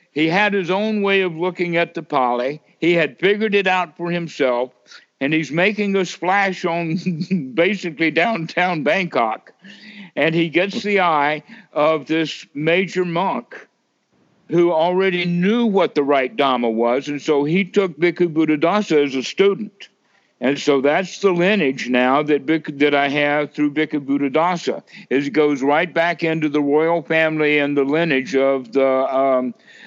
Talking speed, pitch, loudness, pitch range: 160 wpm, 160 Hz, -18 LUFS, 145-185 Hz